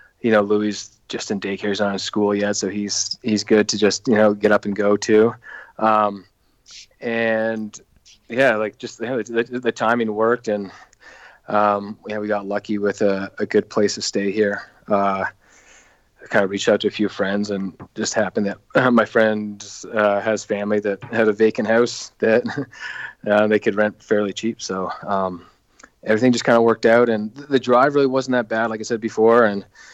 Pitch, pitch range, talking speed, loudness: 105 Hz, 100-115 Hz, 200 wpm, -20 LUFS